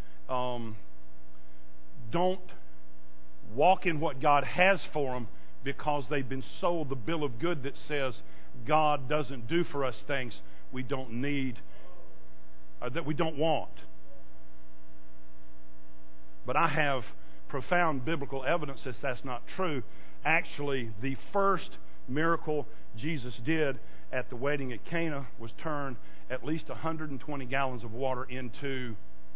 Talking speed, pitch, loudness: 130 wpm, 130 Hz, -32 LUFS